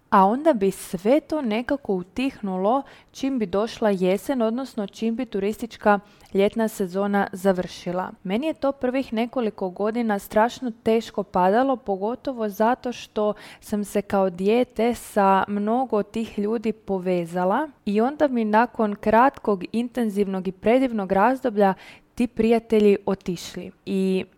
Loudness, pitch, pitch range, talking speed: -23 LUFS, 215 Hz, 195-240 Hz, 130 wpm